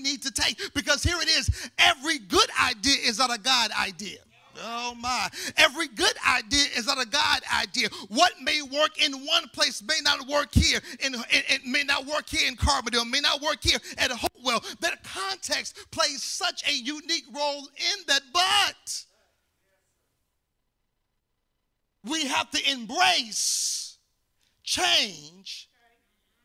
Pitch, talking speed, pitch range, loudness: 285 Hz, 145 wpm, 255-315 Hz, -24 LUFS